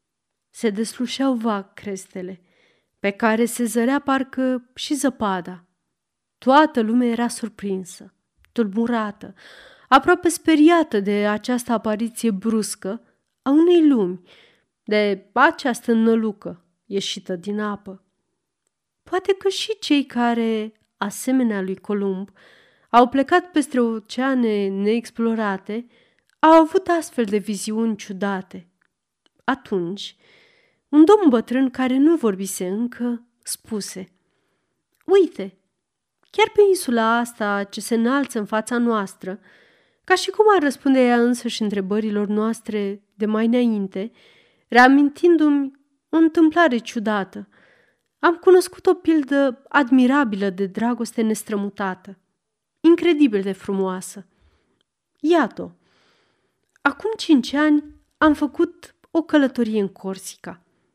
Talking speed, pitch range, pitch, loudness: 105 wpm, 205-285 Hz, 230 Hz, -20 LUFS